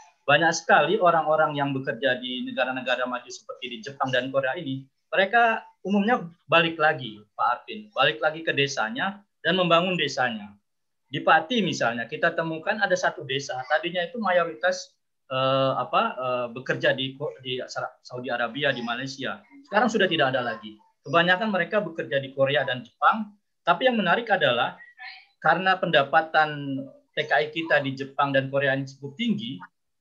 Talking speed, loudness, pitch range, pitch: 145 wpm, -24 LUFS, 130-190 Hz, 155 Hz